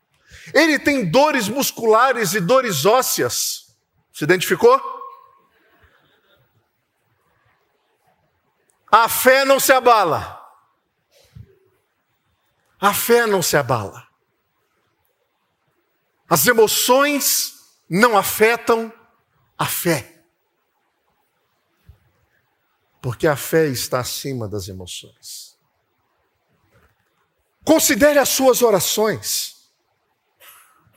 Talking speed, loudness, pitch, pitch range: 70 wpm, -17 LUFS, 235 Hz, 170-285 Hz